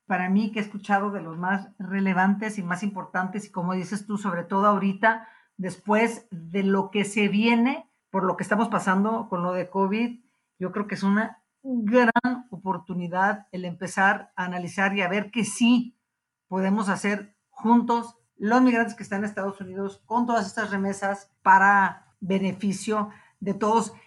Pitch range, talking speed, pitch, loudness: 190-225 Hz, 170 wpm, 200 Hz, -25 LUFS